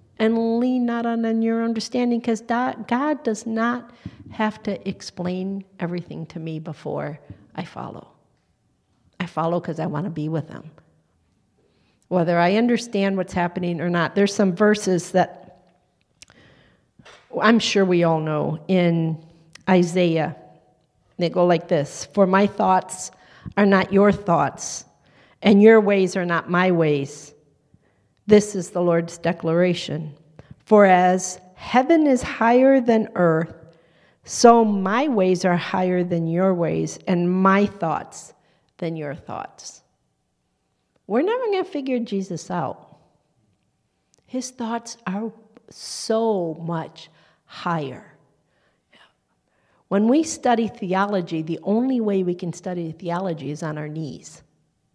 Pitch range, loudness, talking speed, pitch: 170-220 Hz, -21 LUFS, 130 wpm, 185 Hz